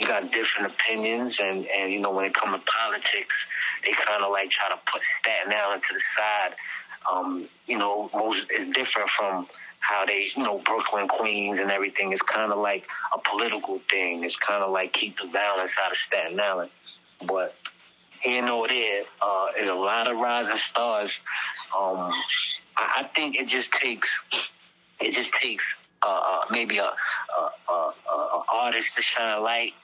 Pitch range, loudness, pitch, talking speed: 95-115 Hz, -25 LUFS, 100 Hz, 185 wpm